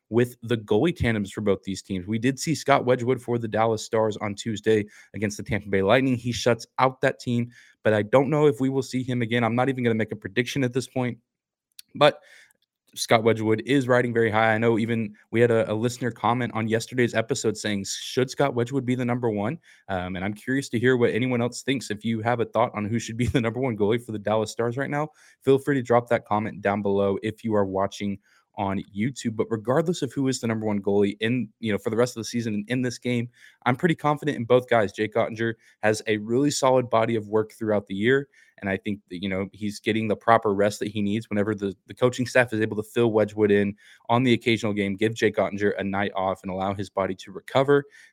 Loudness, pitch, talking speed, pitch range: -25 LUFS, 115 Hz, 250 wpm, 105-125 Hz